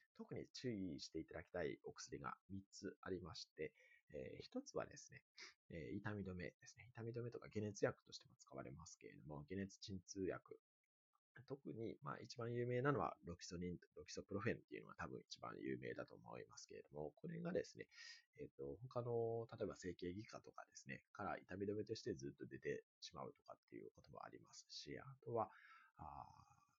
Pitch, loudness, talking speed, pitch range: 115 Hz, -51 LUFS, 380 characters per minute, 95-155 Hz